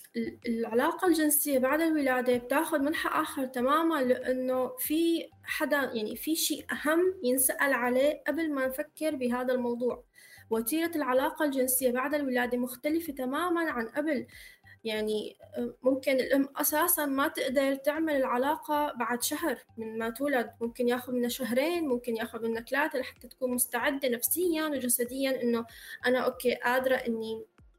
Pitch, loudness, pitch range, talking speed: 260 Hz, -29 LUFS, 245-300 Hz, 135 wpm